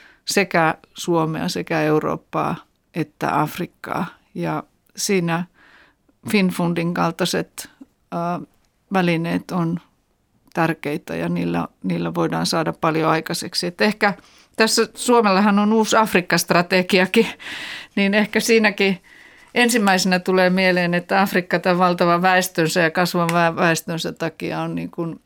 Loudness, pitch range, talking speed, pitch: -19 LUFS, 165-200 Hz, 110 wpm, 180 Hz